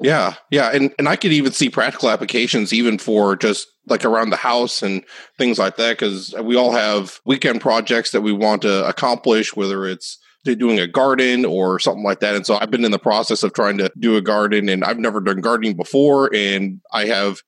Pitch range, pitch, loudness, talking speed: 100-120 Hz, 110 Hz, -17 LUFS, 215 wpm